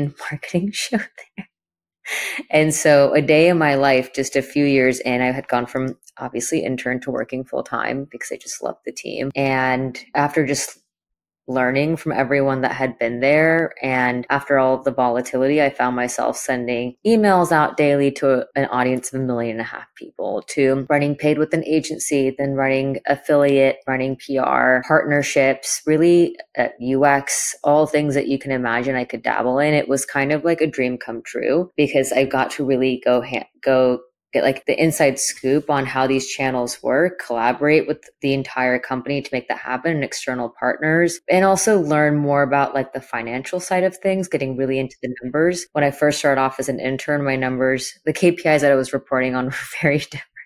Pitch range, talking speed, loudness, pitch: 130-150 Hz, 195 wpm, -19 LUFS, 135 Hz